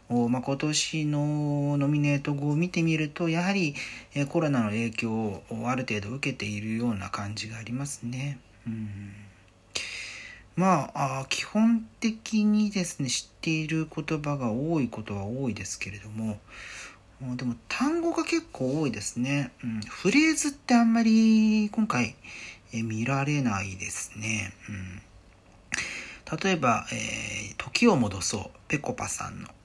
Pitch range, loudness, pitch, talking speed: 110-160 Hz, -28 LUFS, 130 Hz, 265 characters per minute